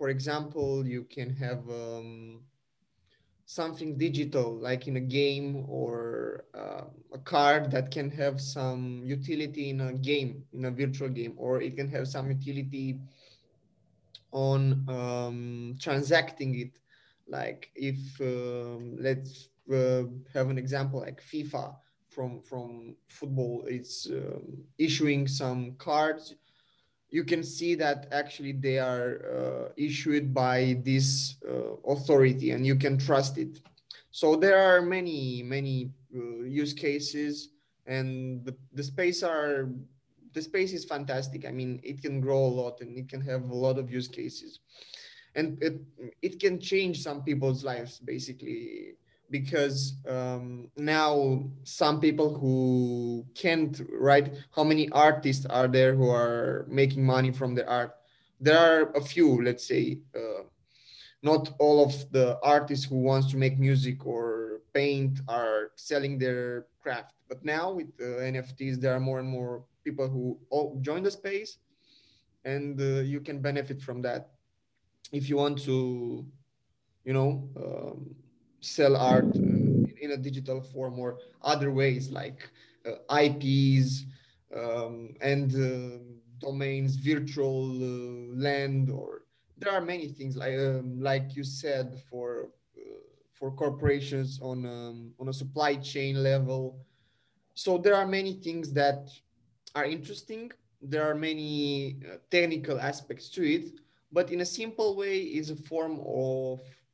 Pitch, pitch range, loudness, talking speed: 135 Hz, 130-150 Hz, -29 LUFS, 145 wpm